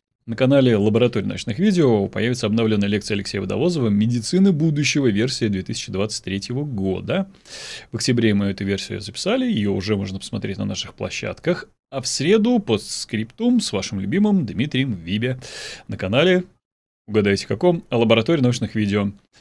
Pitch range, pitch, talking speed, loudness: 105-145 Hz, 115 Hz, 140 wpm, -21 LUFS